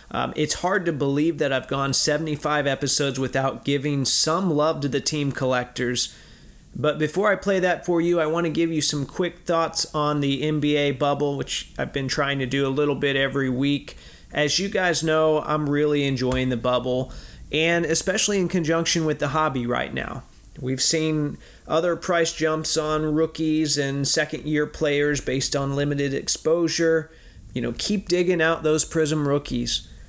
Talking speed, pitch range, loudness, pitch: 180 wpm, 140-160 Hz, -22 LUFS, 150 Hz